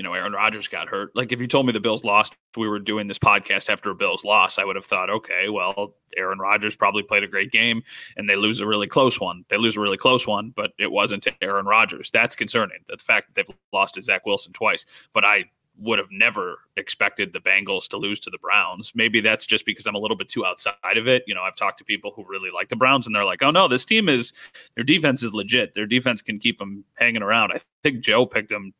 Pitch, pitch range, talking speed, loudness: 110 Hz, 100-125 Hz, 265 wpm, -21 LUFS